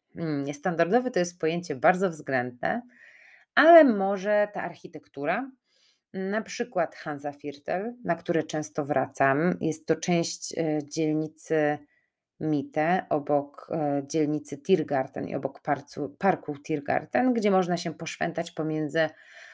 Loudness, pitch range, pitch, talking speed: -27 LUFS, 150-185 Hz, 160 Hz, 105 wpm